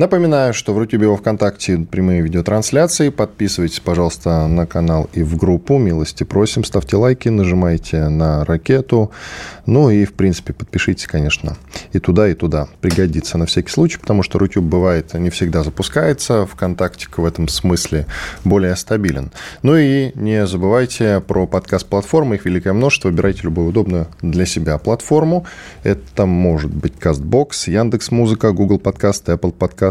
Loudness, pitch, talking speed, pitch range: -16 LUFS, 95 Hz, 145 wpm, 85-110 Hz